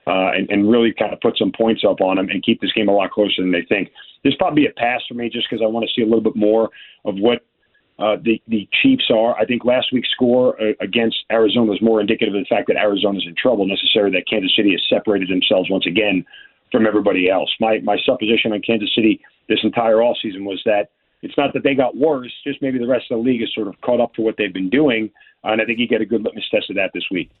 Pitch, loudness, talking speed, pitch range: 115 Hz, -17 LUFS, 270 wpm, 105-120 Hz